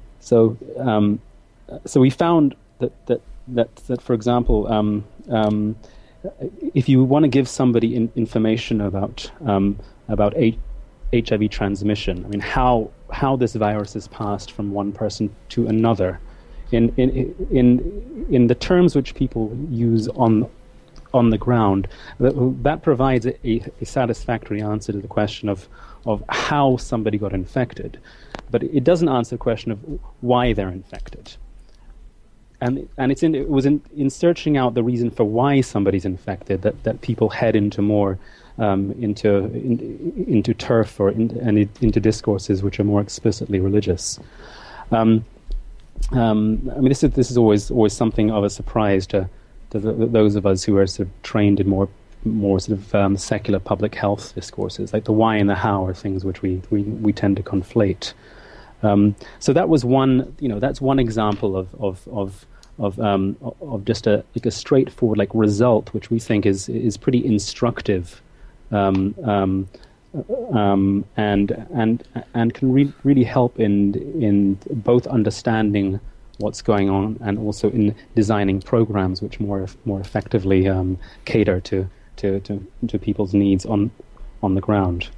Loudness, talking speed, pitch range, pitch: -20 LUFS, 165 wpm, 100-120 Hz, 110 Hz